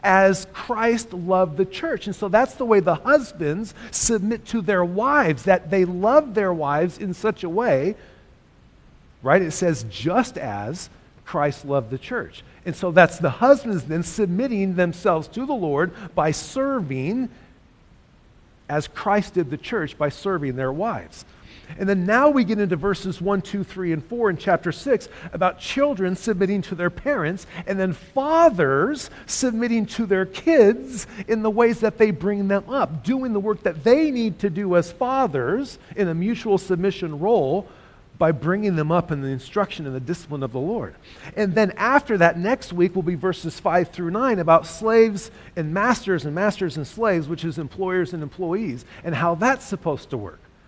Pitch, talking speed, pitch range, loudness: 190 Hz, 180 wpm, 165-220 Hz, -22 LUFS